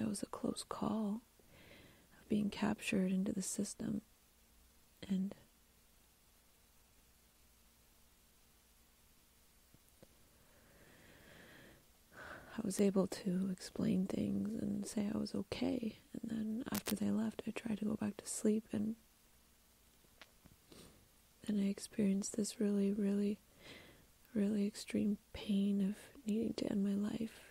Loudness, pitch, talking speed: -39 LUFS, 205 Hz, 110 wpm